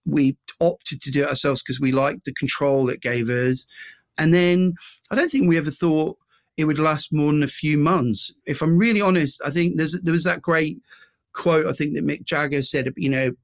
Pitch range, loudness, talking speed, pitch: 135-165 Hz, -21 LUFS, 225 wpm, 150 Hz